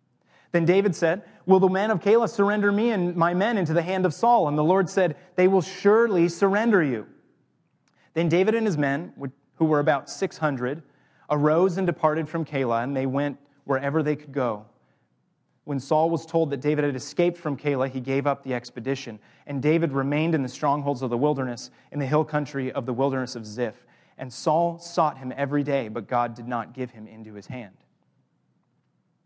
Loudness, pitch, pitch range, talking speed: -24 LUFS, 150 Hz, 135-175 Hz, 200 wpm